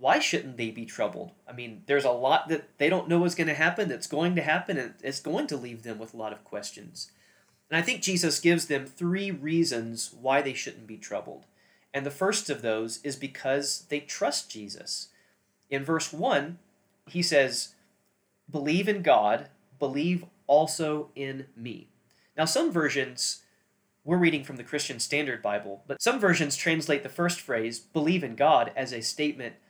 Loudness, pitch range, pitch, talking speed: -28 LUFS, 130-165 Hz, 145 Hz, 185 wpm